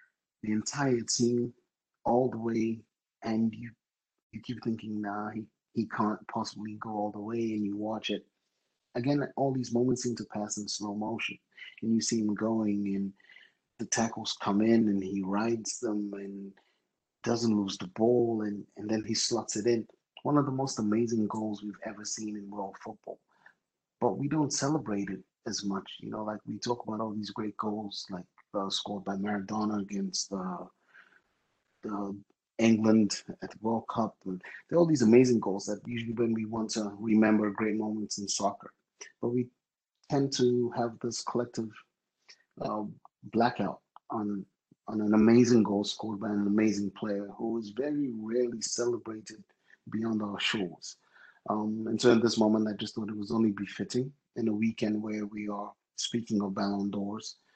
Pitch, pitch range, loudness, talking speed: 110 Hz, 105-115 Hz, -31 LUFS, 175 wpm